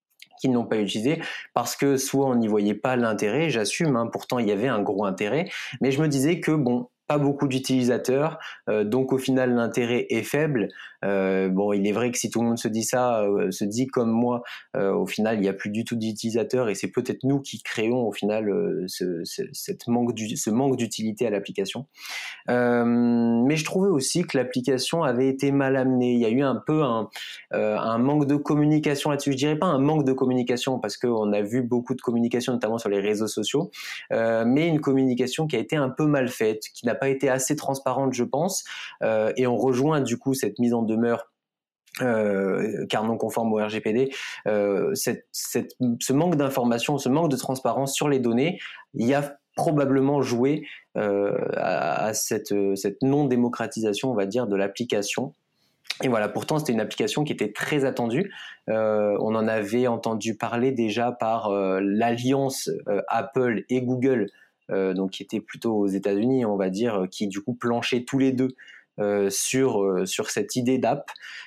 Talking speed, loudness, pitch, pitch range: 200 wpm, -24 LUFS, 125 Hz, 110-135 Hz